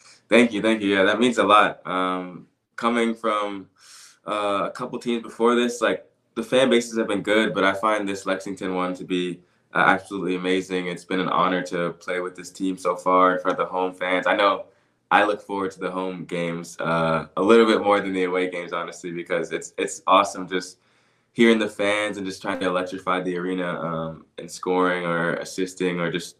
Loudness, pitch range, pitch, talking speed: -23 LUFS, 90-105 Hz, 95 Hz, 215 wpm